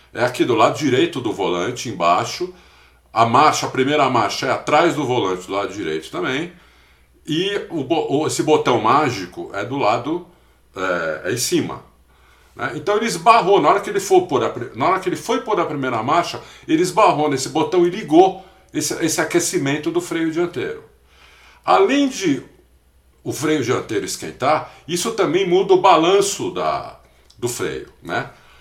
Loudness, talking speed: -19 LUFS, 170 wpm